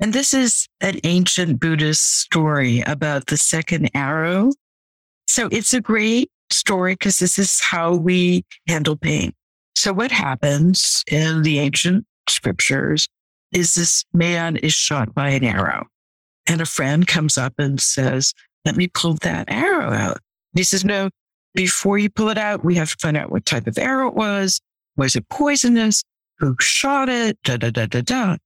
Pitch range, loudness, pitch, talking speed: 145-200 Hz, -18 LUFS, 170 Hz, 175 wpm